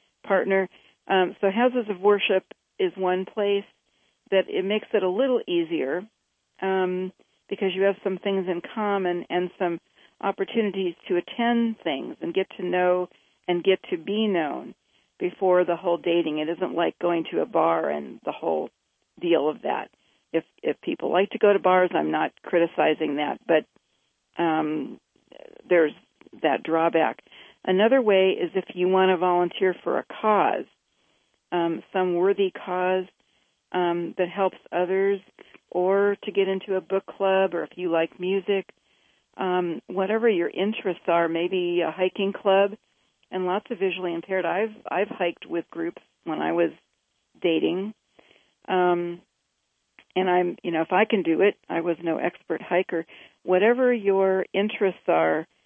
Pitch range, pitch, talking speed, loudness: 175-200 Hz, 185 Hz, 155 wpm, -25 LUFS